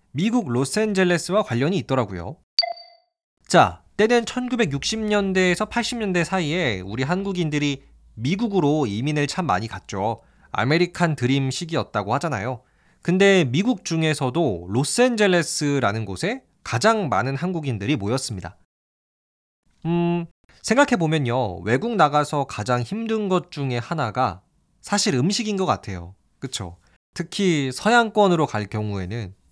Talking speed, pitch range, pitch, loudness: 285 characters per minute, 125-195 Hz, 155 Hz, -22 LUFS